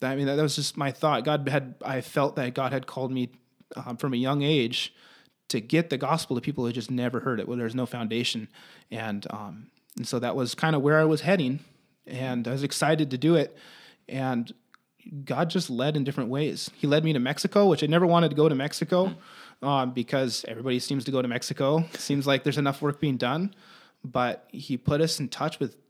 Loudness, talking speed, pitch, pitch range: -27 LUFS, 225 wpm, 140 Hz, 125-155 Hz